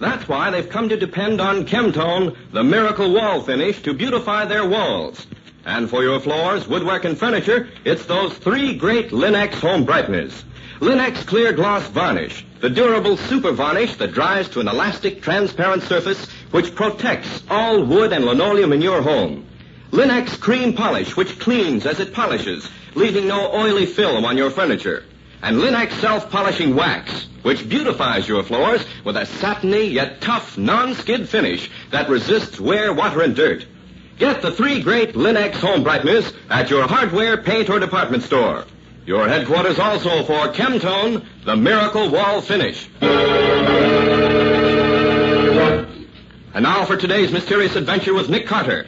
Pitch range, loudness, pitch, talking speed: 190-225 Hz, -17 LUFS, 205 Hz, 150 wpm